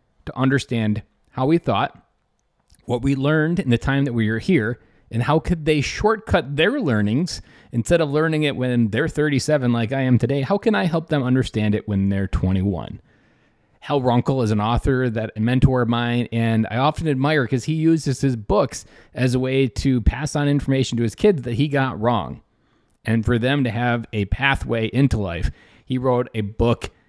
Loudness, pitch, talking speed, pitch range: -21 LUFS, 125 Hz, 195 wpm, 115-145 Hz